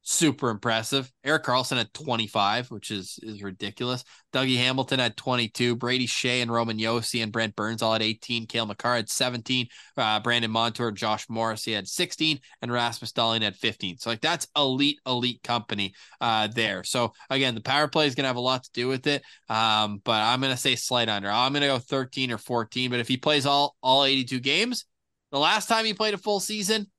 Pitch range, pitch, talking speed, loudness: 115-135 Hz, 125 Hz, 205 wpm, -25 LUFS